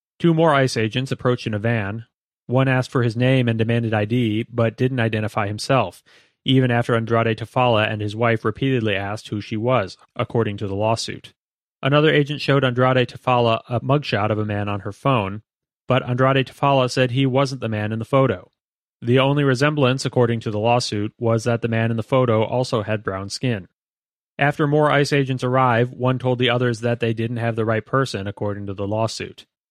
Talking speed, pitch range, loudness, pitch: 200 wpm, 110-130 Hz, -20 LUFS, 120 Hz